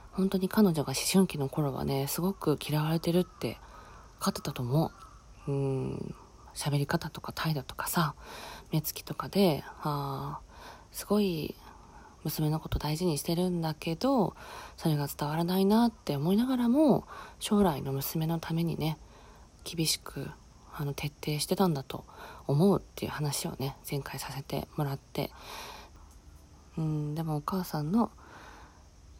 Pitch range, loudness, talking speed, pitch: 140-180 Hz, -31 LUFS, 270 characters per minute, 155 Hz